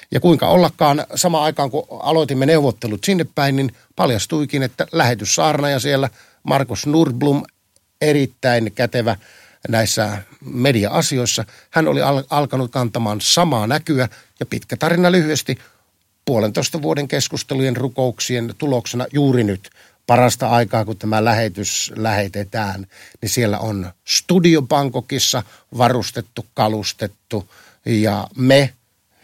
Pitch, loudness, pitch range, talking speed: 125 Hz, -18 LUFS, 110-140 Hz, 110 wpm